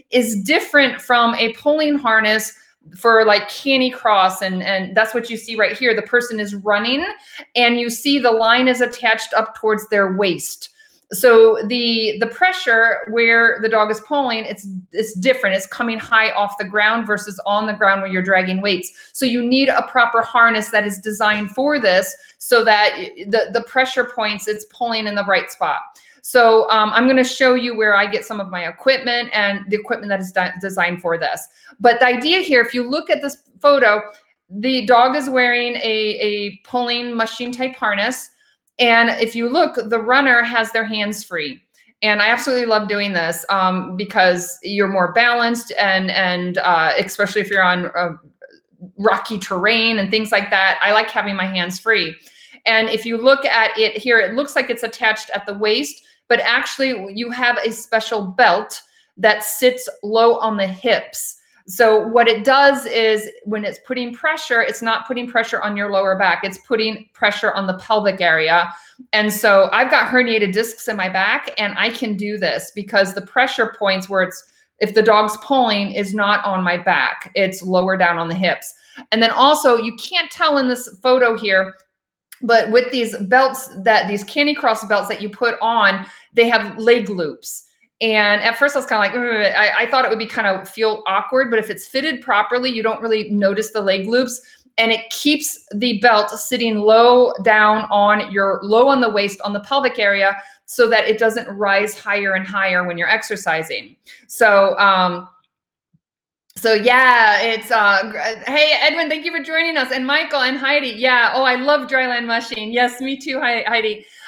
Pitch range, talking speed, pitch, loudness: 205-245 Hz, 190 wpm, 225 Hz, -16 LUFS